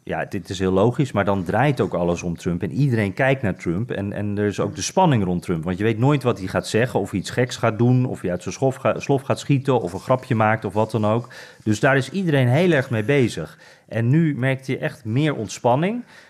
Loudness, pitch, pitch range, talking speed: -21 LUFS, 120 Hz, 100-135 Hz, 260 wpm